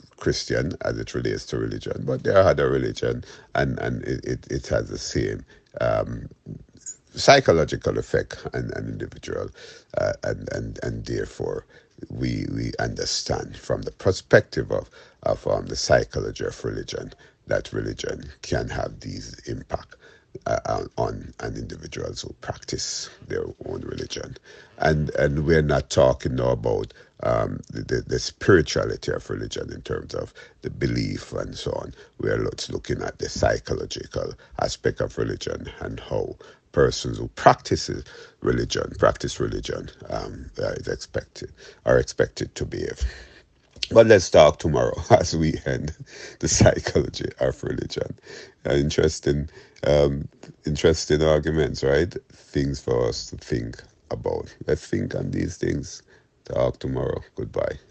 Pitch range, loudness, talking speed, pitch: 70-75 Hz, -24 LUFS, 140 wpm, 75 Hz